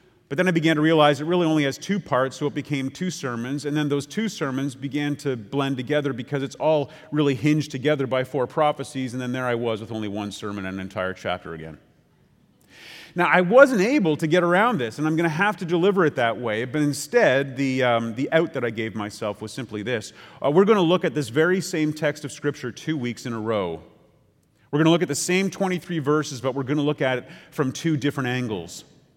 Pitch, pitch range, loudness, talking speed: 145 Hz, 125-160 Hz, -23 LUFS, 240 wpm